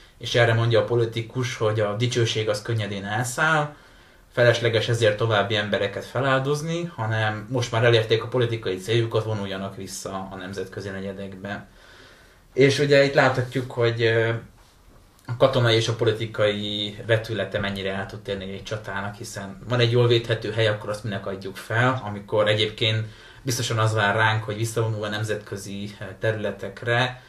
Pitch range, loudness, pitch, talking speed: 100-120 Hz, -23 LUFS, 110 Hz, 145 wpm